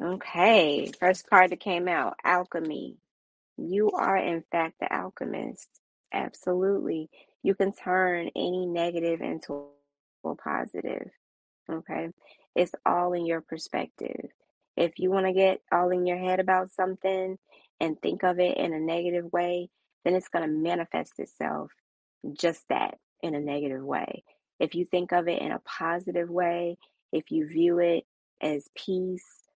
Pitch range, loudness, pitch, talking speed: 165-185 Hz, -28 LUFS, 175 Hz, 150 wpm